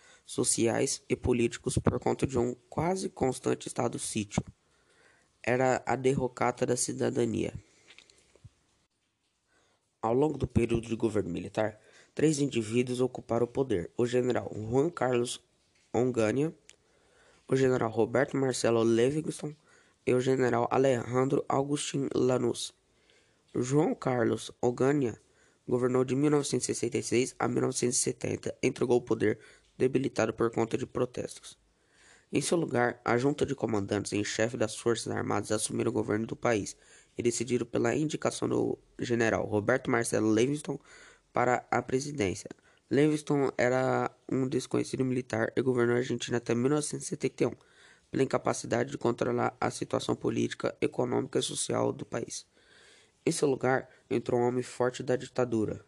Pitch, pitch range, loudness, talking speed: 125 Hz, 115-130 Hz, -30 LUFS, 130 wpm